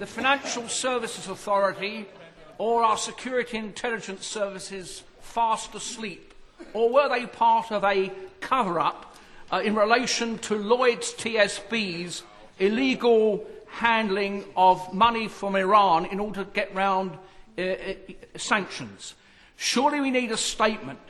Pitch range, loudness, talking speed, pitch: 195-230 Hz, -25 LUFS, 120 wpm, 215 Hz